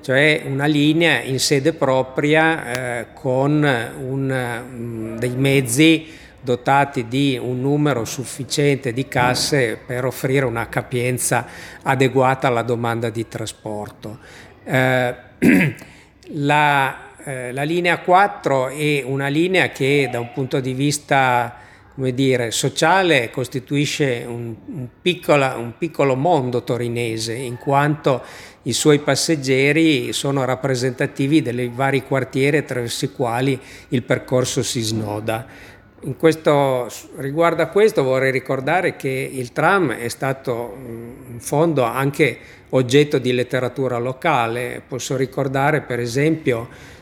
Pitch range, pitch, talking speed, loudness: 120-145 Hz, 130 Hz, 115 wpm, -19 LUFS